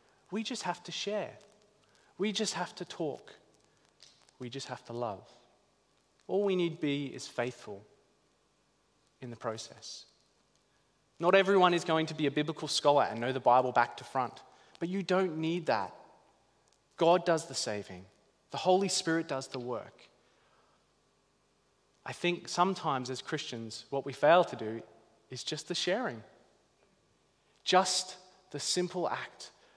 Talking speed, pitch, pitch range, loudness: 145 wpm, 155 Hz, 130-180 Hz, -32 LUFS